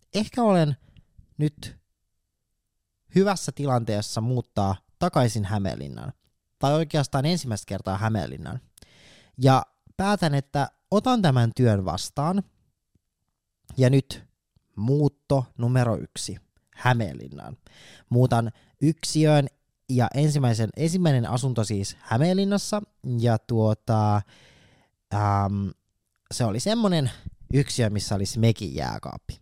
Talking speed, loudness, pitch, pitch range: 90 wpm, -24 LUFS, 120 Hz, 105-145 Hz